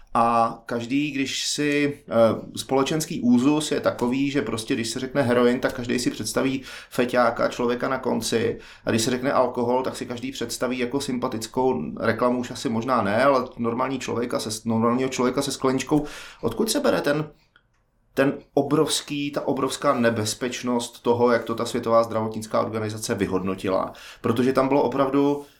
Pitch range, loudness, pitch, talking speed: 115-140 Hz, -24 LUFS, 125 Hz, 155 wpm